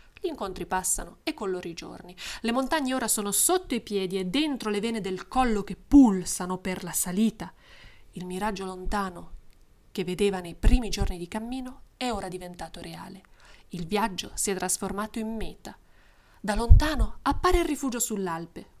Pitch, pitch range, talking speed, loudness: 205 Hz, 185-235 Hz, 165 wpm, -27 LUFS